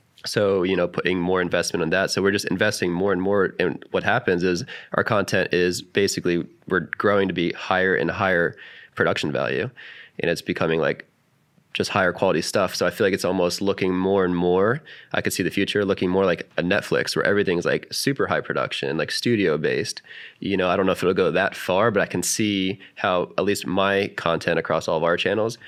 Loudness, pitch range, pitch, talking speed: -22 LUFS, 90-100 Hz, 95 Hz, 220 wpm